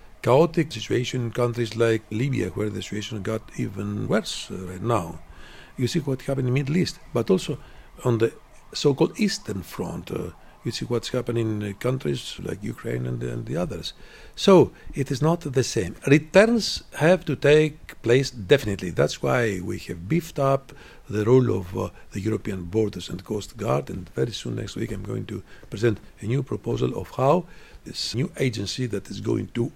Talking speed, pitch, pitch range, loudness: 190 wpm, 120 Hz, 105-140 Hz, -25 LUFS